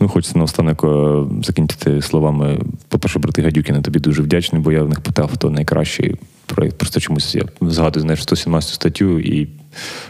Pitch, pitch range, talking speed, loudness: 80 Hz, 75-80 Hz, 170 wpm, -17 LUFS